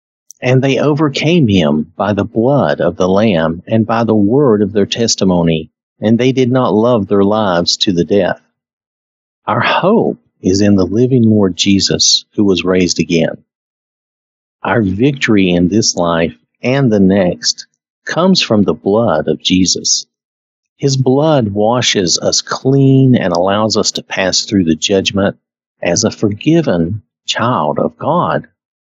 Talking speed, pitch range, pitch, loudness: 150 wpm, 85-125 Hz, 105 Hz, -12 LUFS